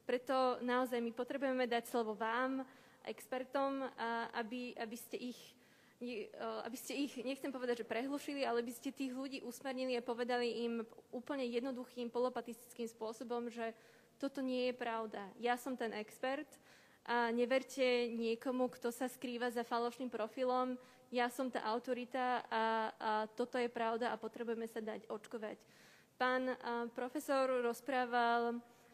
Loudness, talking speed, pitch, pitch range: -40 LUFS, 140 wpm, 245 Hz, 235-255 Hz